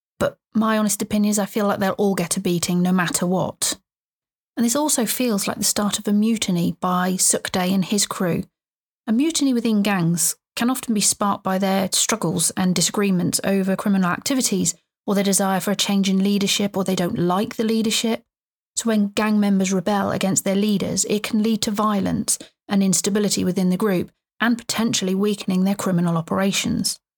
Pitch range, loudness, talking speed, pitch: 190-220 Hz, -20 LUFS, 190 wpm, 200 Hz